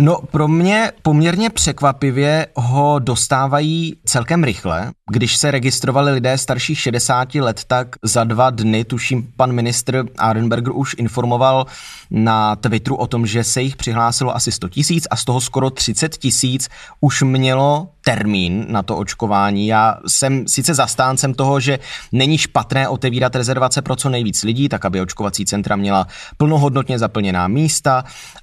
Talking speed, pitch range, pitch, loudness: 150 wpm, 115-140 Hz, 130 Hz, -16 LUFS